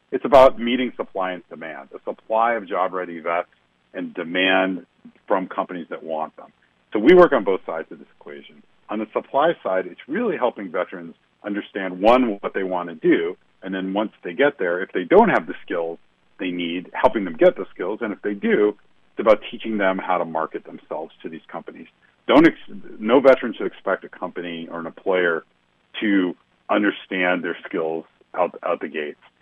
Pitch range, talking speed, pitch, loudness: 85-110 Hz, 195 wpm, 95 Hz, -21 LUFS